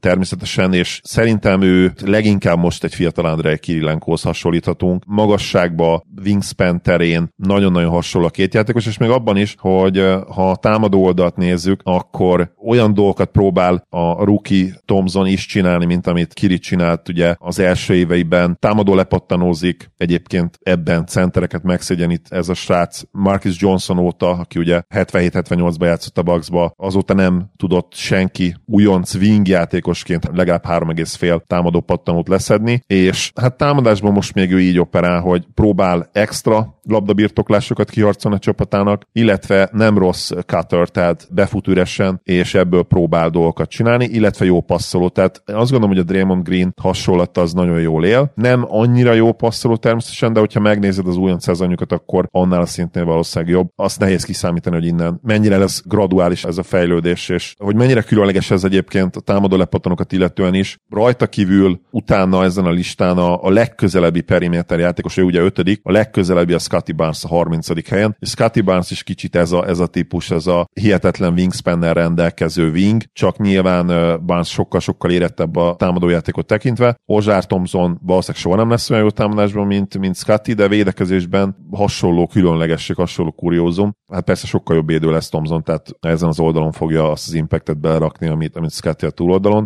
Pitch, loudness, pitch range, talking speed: 90 Hz, -15 LUFS, 85-100 Hz, 165 wpm